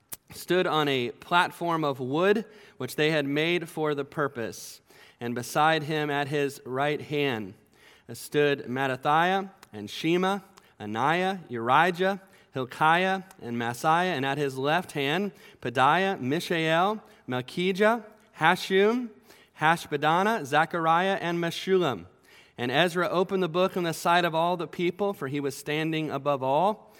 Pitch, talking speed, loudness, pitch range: 160 Hz, 135 wpm, -26 LUFS, 140-185 Hz